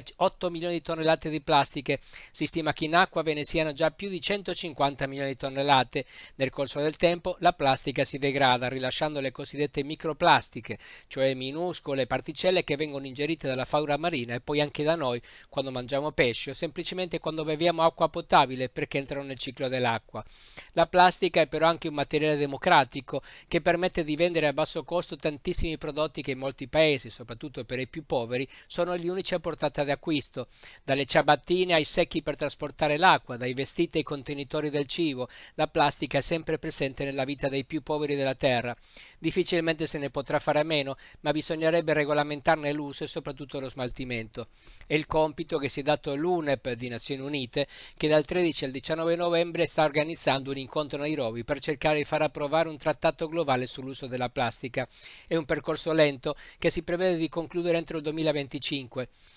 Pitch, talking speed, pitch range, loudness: 150 Hz, 185 wpm, 140-165 Hz, -27 LUFS